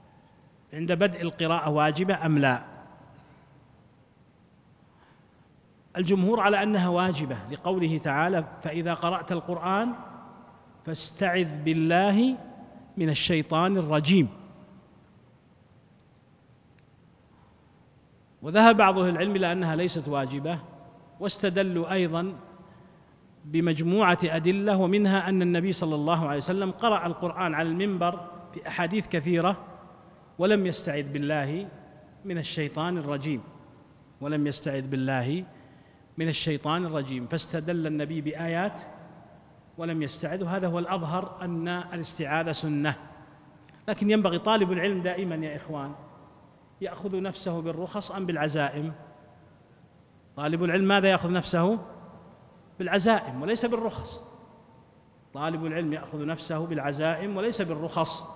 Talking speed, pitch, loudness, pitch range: 100 wpm, 170 Hz, -27 LUFS, 155-185 Hz